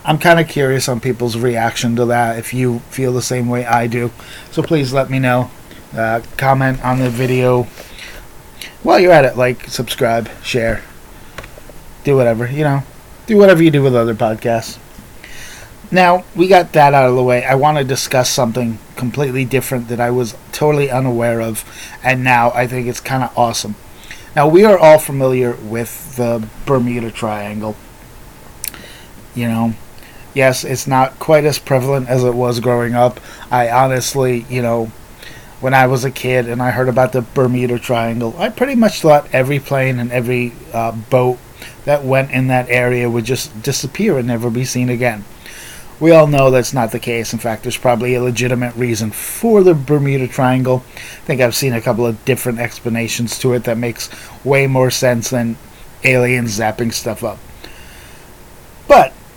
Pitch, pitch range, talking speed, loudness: 125 Hz, 120-135 Hz, 175 wpm, -14 LUFS